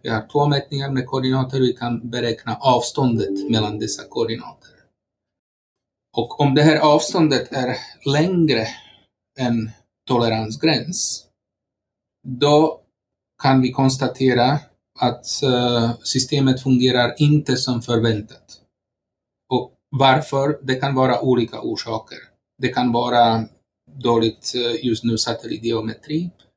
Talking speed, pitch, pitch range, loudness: 110 wpm, 125 Hz, 115-135 Hz, -19 LUFS